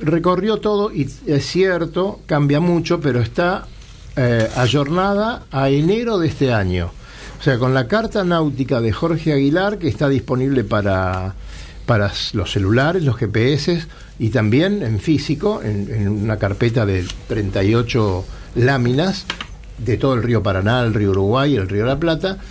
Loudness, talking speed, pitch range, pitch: -18 LUFS, 155 wpm, 105-165 Hz, 130 Hz